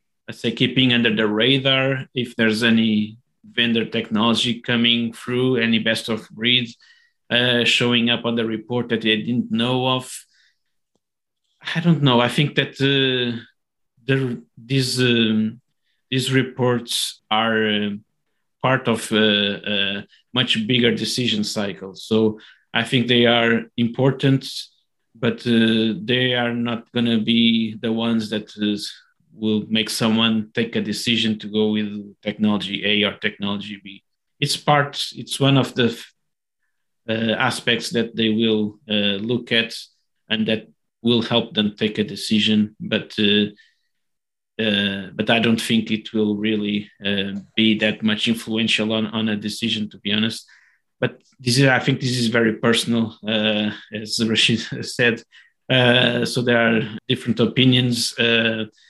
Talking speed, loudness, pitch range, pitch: 150 wpm, -20 LUFS, 110-120 Hz, 115 Hz